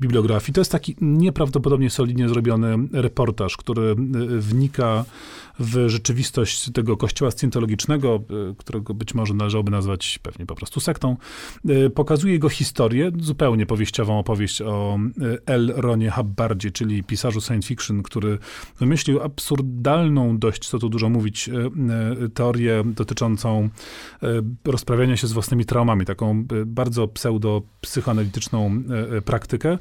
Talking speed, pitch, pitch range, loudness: 115 wpm, 115 Hz, 110-130 Hz, -22 LUFS